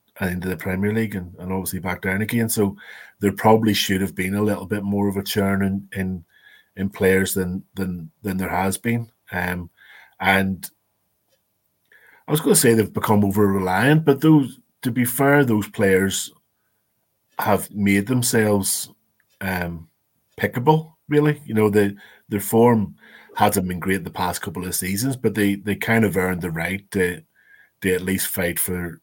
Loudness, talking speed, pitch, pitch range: -21 LUFS, 180 wpm, 100 Hz, 95-110 Hz